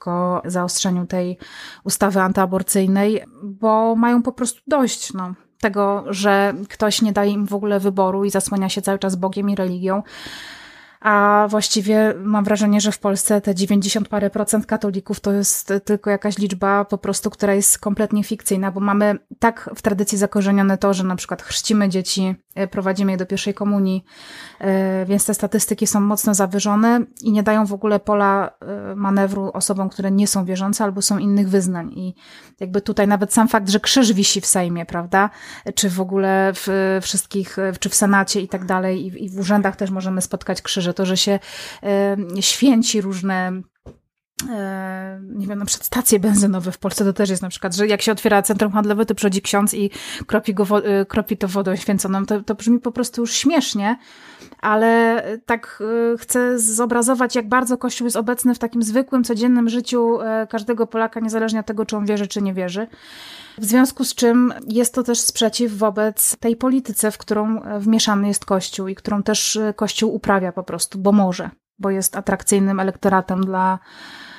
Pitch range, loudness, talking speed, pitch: 195-220 Hz, -19 LUFS, 180 wpm, 205 Hz